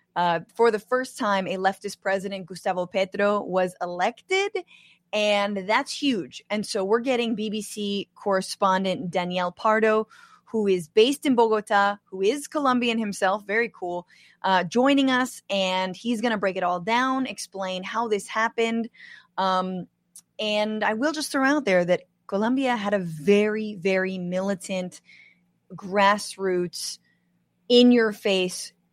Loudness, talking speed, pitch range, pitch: -24 LUFS, 140 wpm, 185-230 Hz, 205 Hz